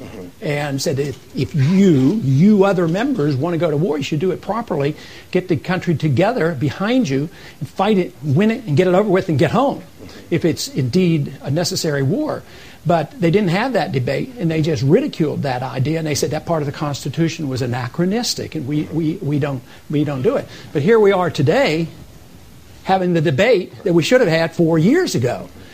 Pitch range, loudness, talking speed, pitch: 145-185 Hz, -18 LUFS, 210 wpm, 160 Hz